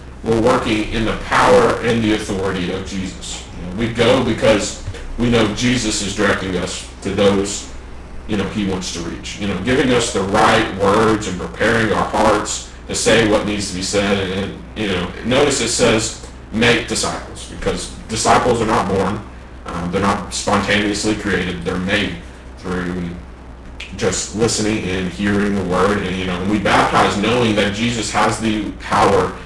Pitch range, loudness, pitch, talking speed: 85-105 Hz, -17 LUFS, 95 Hz, 175 wpm